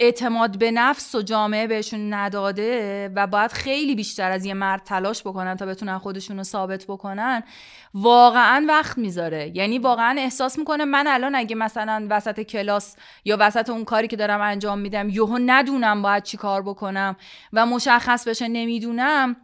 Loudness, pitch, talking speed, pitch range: -21 LUFS, 215 Hz, 165 wpm, 200-240 Hz